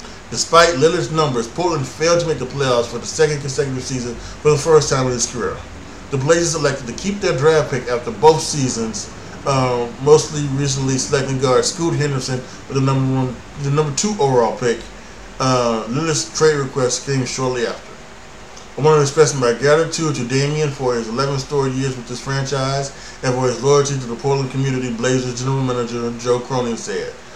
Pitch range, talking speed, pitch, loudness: 125-150 Hz, 185 wpm, 135 Hz, -18 LUFS